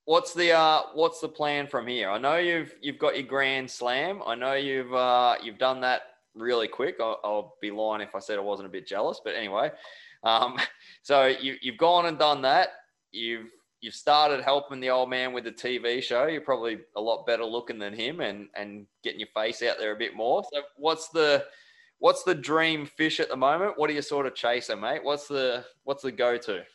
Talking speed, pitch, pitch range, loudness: 220 wpm, 135 Hz, 120-155 Hz, -27 LUFS